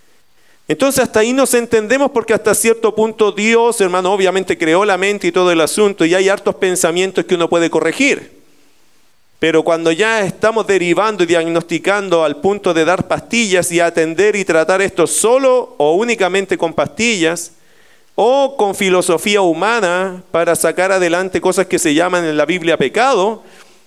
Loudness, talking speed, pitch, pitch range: -14 LUFS, 160 wpm, 190 Hz, 170-215 Hz